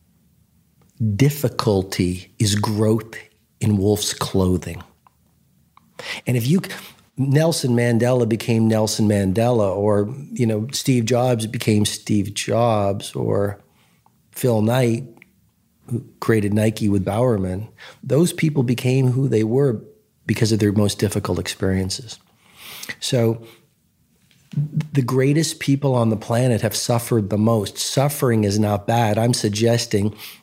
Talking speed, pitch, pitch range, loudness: 115 wpm, 115 Hz, 105-125 Hz, -20 LUFS